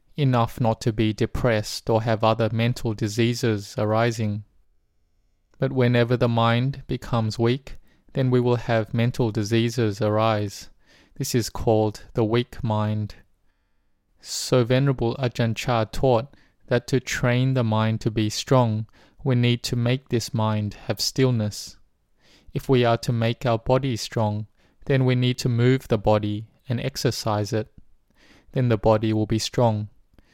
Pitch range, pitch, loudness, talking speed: 110-125 Hz, 115 Hz, -23 LUFS, 150 wpm